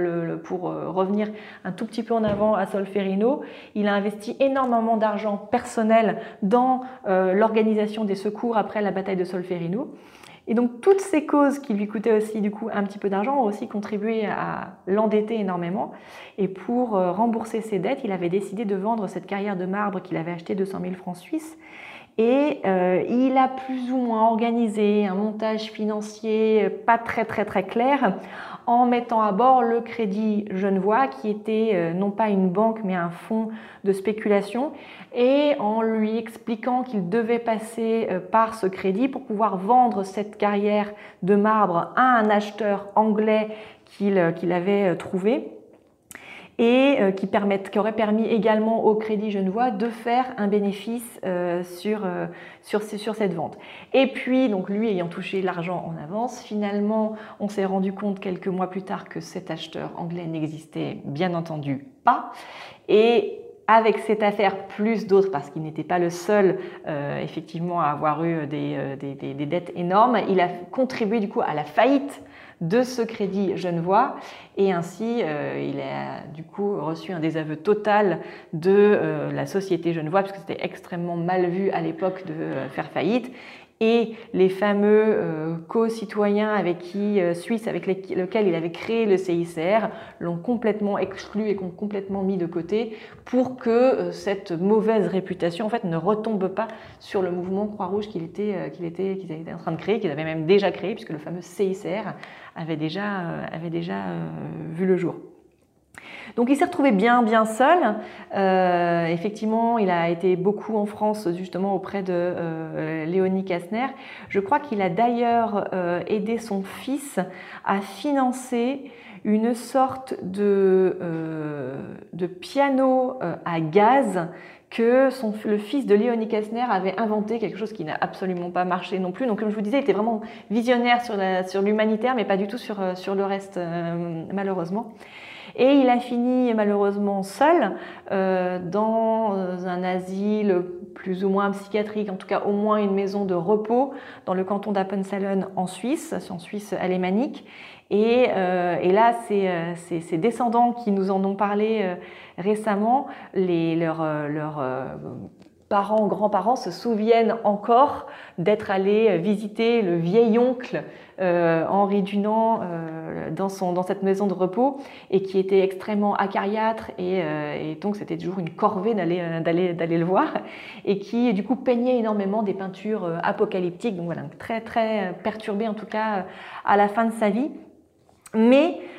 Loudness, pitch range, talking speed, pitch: -23 LUFS, 185-225 Hz, 170 wpm, 205 Hz